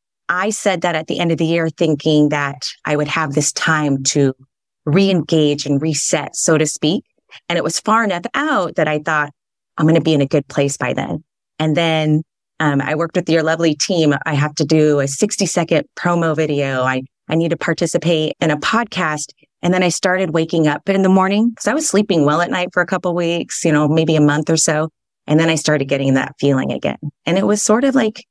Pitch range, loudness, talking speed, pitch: 150-180 Hz, -16 LUFS, 235 wpm, 160 Hz